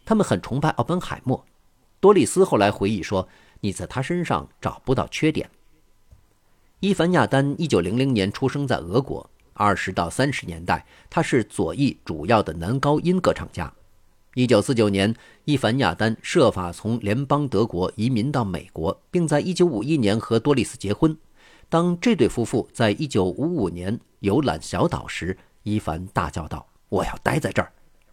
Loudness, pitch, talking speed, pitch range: -23 LUFS, 115 Hz, 260 characters per minute, 95-145 Hz